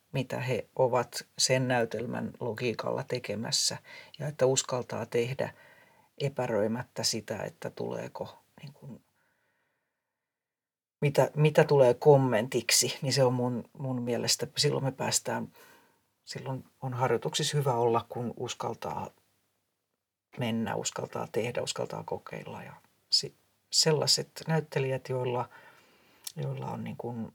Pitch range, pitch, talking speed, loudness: 120-145 Hz, 130 Hz, 110 wpm, -29 LUFS